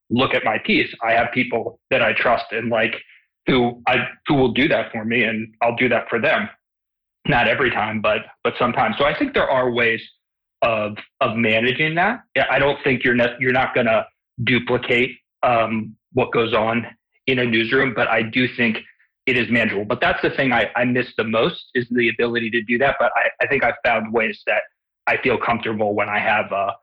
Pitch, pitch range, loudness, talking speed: 120 Hz, 115-125 Hz, -19 LUFS, 215 wpm